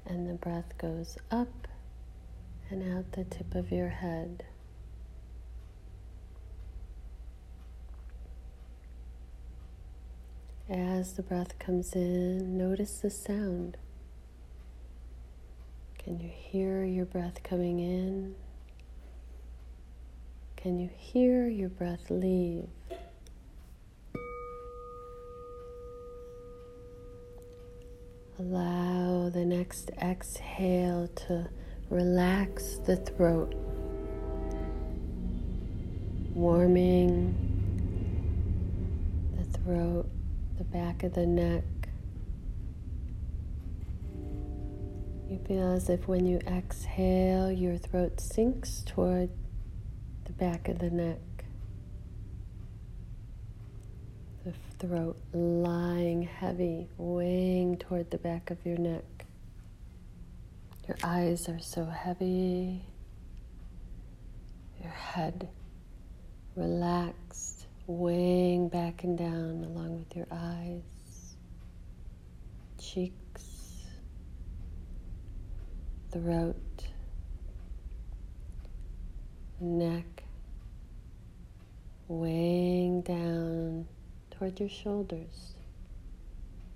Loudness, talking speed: -33 LUFS, 70 wpm